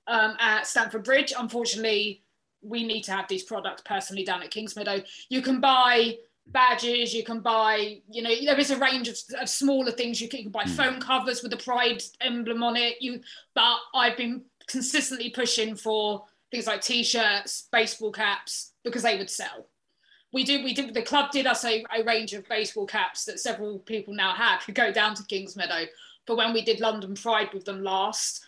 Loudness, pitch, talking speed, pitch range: -26 LUFS, 230 Hz, 200 wpm, 215-250 Hz